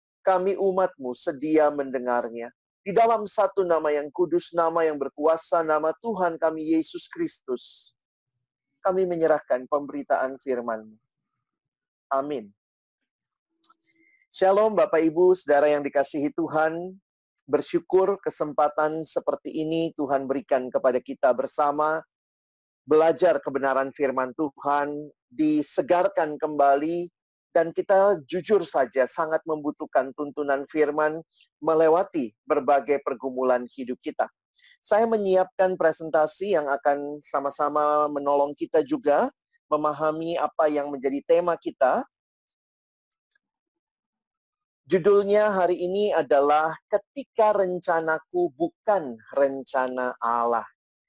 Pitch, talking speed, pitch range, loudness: 155 Hz, 95 wpm, 140-190 Hz, -24 LUFS